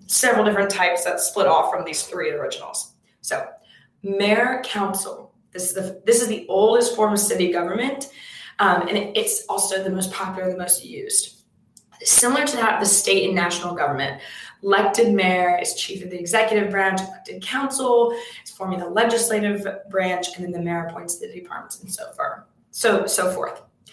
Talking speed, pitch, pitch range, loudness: 175 wpm, 200 Hz, 185-245 Hz, -20 LUFS